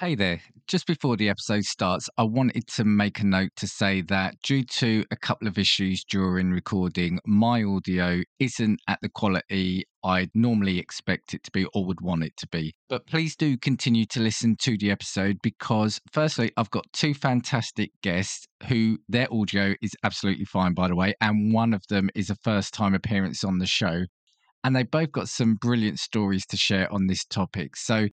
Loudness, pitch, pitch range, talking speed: -25 LUFS, 105 Hz, 95-115 Hz, 195 wpm